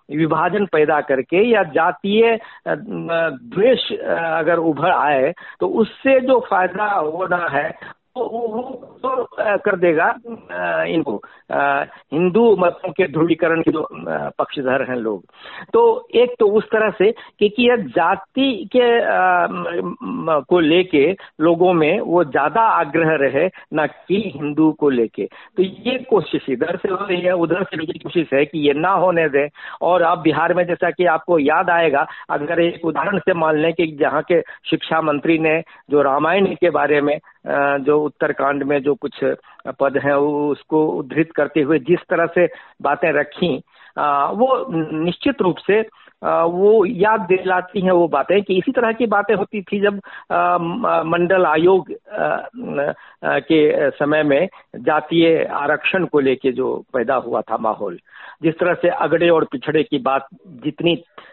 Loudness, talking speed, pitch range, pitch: -18 LUFS, 155 wpm, 155-200 Hz, 170 Hz